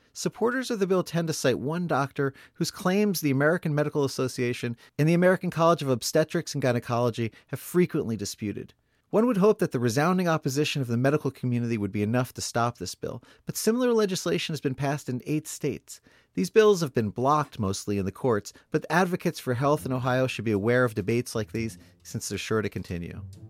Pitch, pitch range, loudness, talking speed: 135 Hz, 115-165 Hz, -26 LUFS, 205 wpm